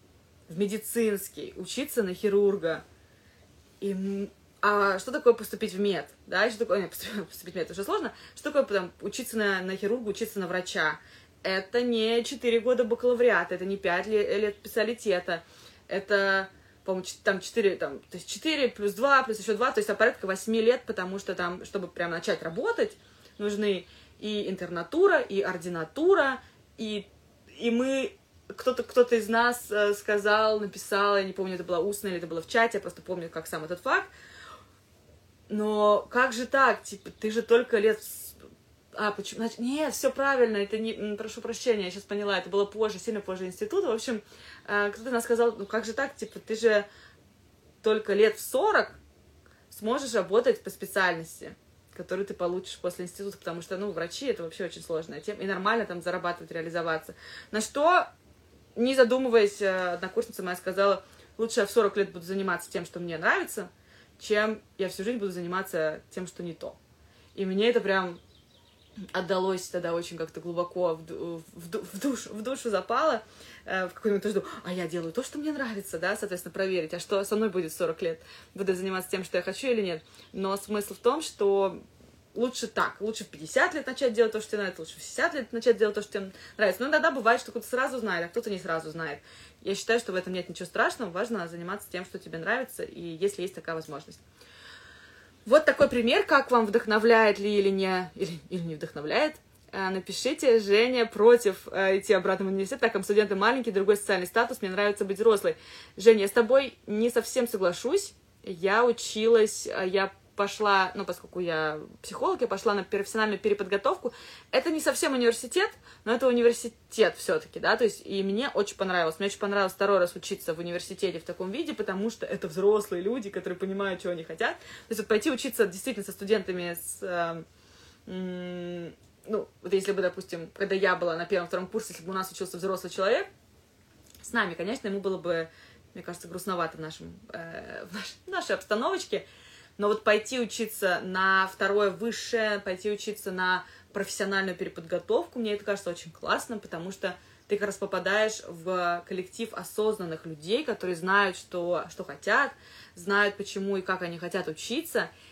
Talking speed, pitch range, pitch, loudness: 185 wpm, 185-230 Hz, 200 Hz, -28 LUFS